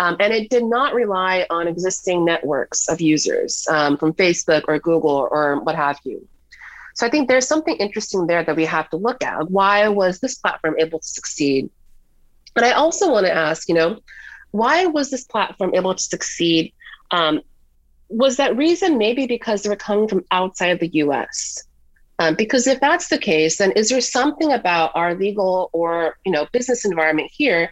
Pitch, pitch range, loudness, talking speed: 185 Hz, 160-240 Hz, -19 LUFS, 190 wpm